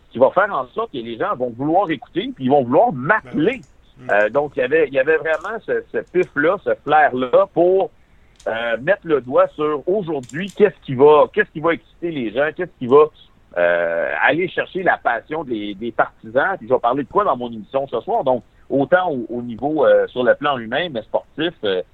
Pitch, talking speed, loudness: 155 Hz, 225 wpm, -19 LUFS